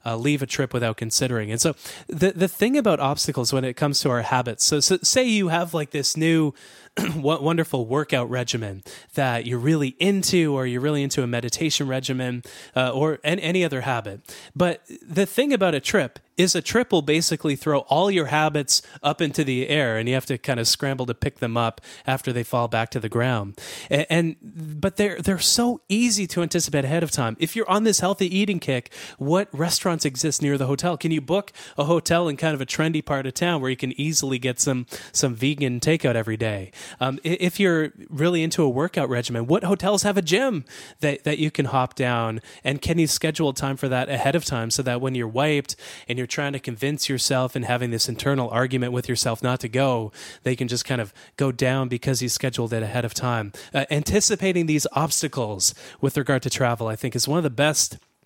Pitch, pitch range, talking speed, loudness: 140 Hz, 125-165 Hz, 220 wpm, -23 LUFS